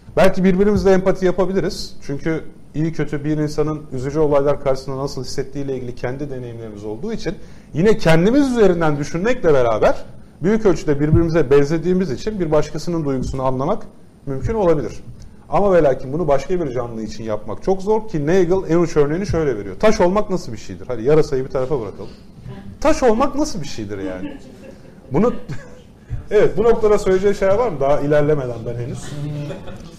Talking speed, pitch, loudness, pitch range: 160 wpm, 155 Hz, -19 LUFS, 135-190 Hz